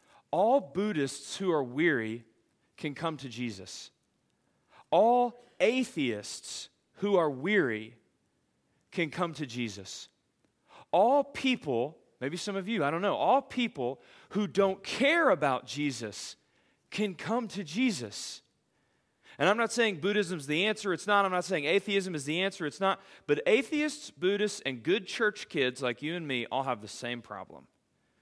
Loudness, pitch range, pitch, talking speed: -30 LUFS, 130-210 Hz, 185 Hz, 155 wpm